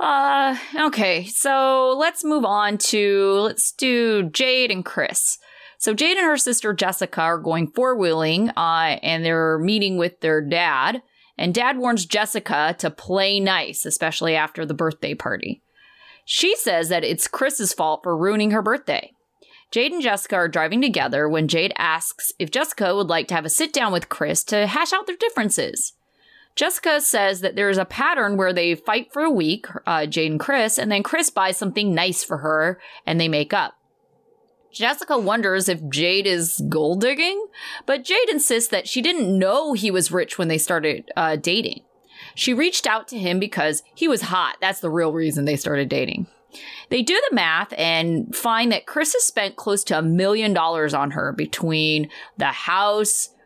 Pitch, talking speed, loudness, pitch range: 195 Hz, 185 wpm, -20 LUFS, 165-250 Hz